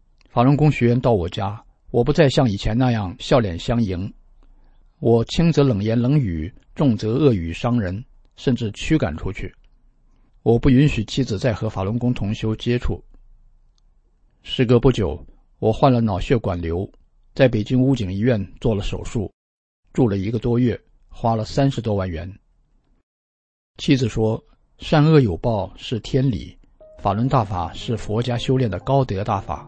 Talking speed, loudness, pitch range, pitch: 230 characters per minute, -20 LUFS, 100-130 Hz, 115 Hz